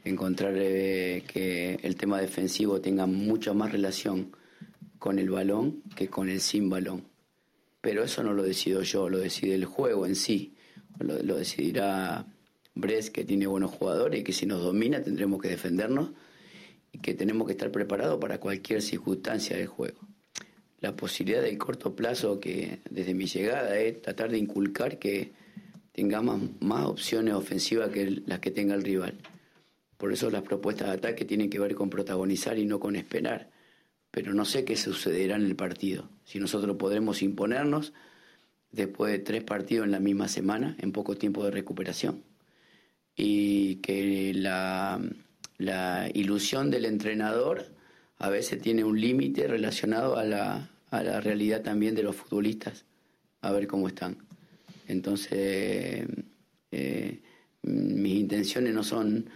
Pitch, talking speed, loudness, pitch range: 100 Hz, 155 wpm, -30 LUFS, 95-105 Hz